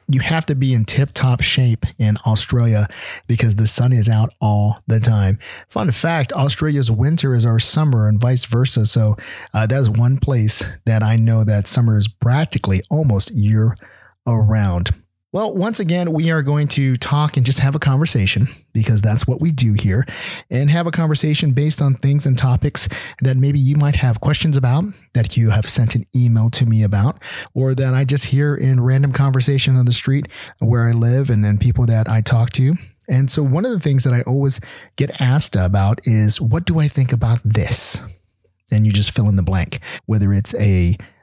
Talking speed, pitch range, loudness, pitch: 200 wpm, 110-140 Hz, -16 LUFS, 125 Hz